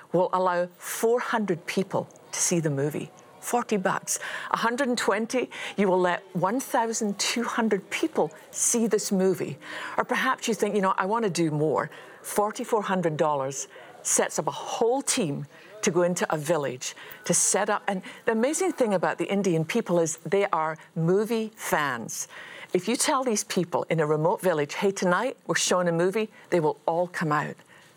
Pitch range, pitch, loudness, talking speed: 175-230 Hz, 190 Hz, -26 LUFS, 165 wpm